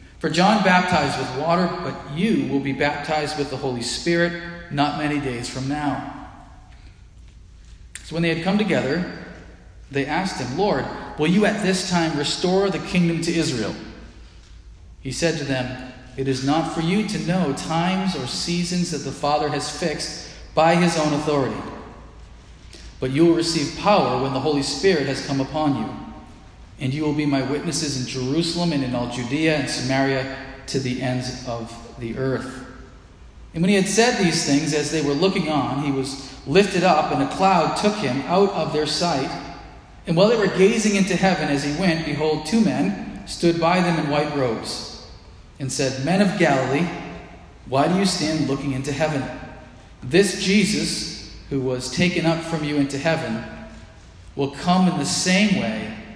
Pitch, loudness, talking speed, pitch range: 150 Hz, -21 LUFS, 180 wpm, 130-170 Hz